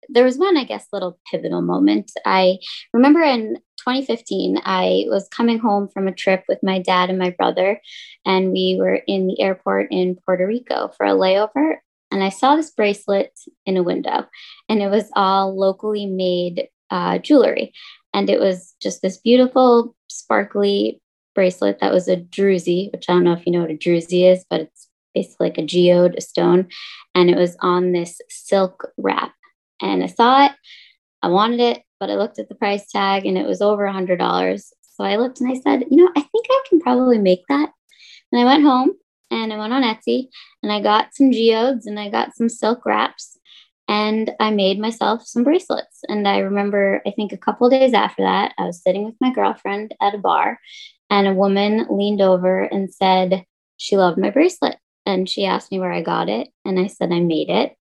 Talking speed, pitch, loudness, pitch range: 205 wpm, 200 Hz, -18 LUFS, 185-245 Hz